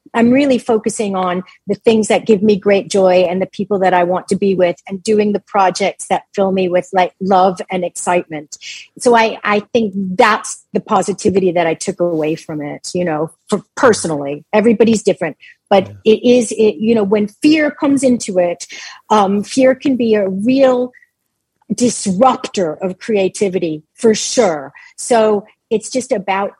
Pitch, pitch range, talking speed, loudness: 205 Hz, 185-225 Hz, 175 wpm, -15 LUFS